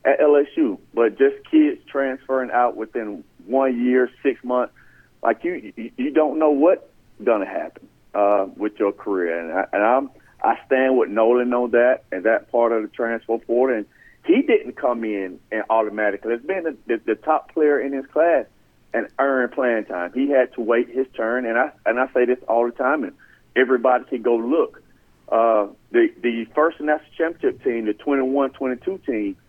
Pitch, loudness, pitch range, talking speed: 125 Hz, -21 LUFS, 115-150 Hz, 195 wpm